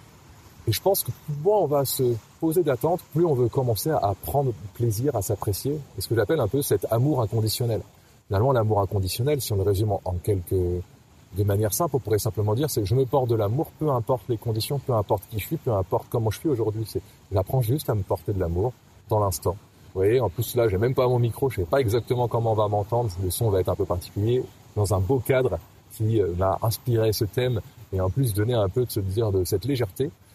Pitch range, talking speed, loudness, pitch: 100-130 Hz, 245 wpm, -25 LUFS, 115 Hz